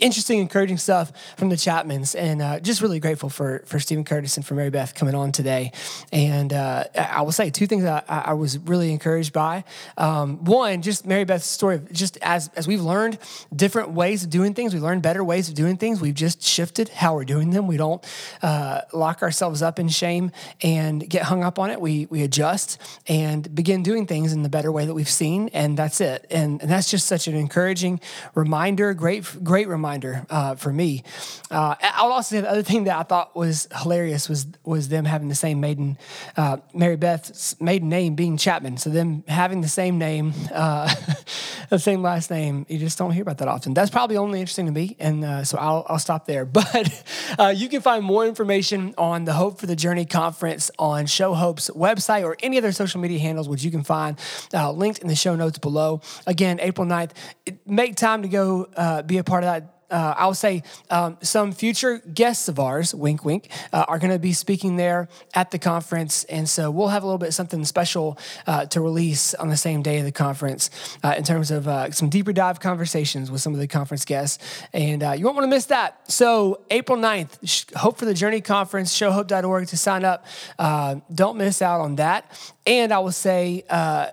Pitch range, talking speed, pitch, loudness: 155-190 Hz, 215 wpm, 170 Hz, -22 LUFS